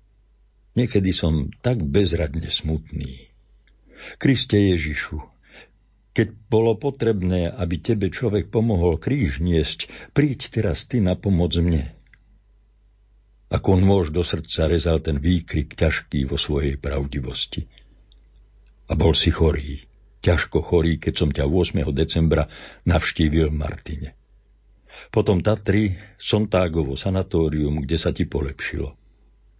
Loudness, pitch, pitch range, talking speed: -22 LUFS, 90 Hz, 80-105 Hz, 110 wpm